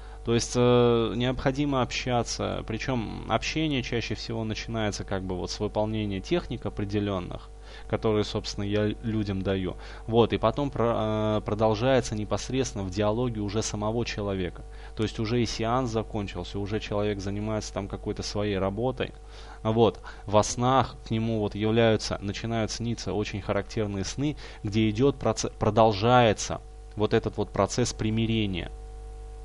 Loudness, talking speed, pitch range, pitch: -27 LUFS, 135 wpm, 105-115 Hz, 110 Hz